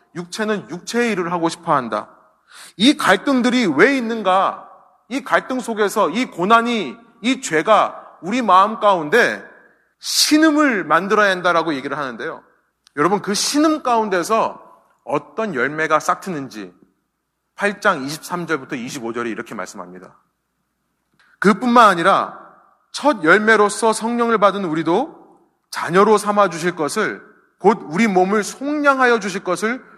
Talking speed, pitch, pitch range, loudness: 270 characters per minute, 210 Hz, 180-240 Hz, -17 LUFS